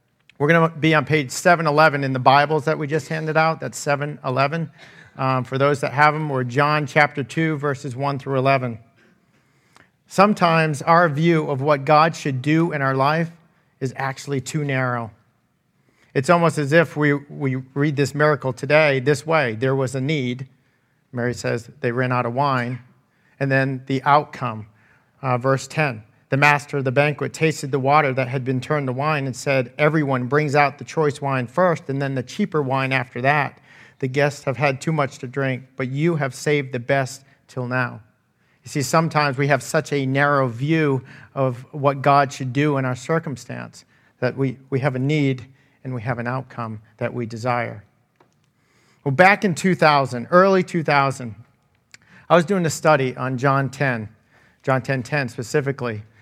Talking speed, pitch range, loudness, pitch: 185 wpm, 130-150 Hz, -20 LUFS, 140 Hz